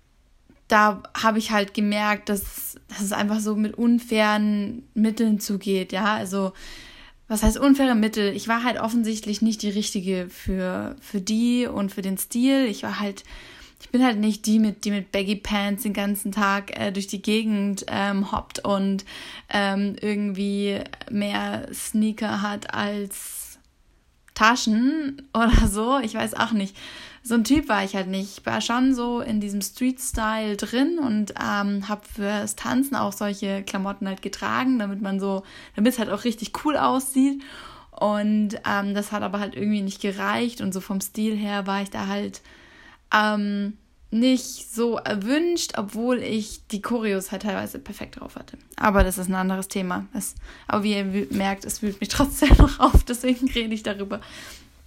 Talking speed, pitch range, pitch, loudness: 170 wpm, 200-230 Hz, 210 Hz, -24 LUFS